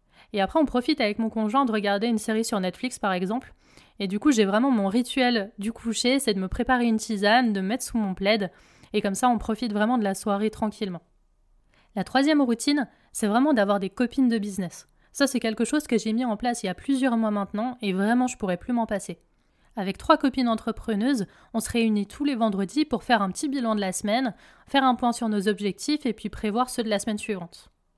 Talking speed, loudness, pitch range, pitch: 235 wpm, -25 LUFS, 200-245 Hz, 225 Hz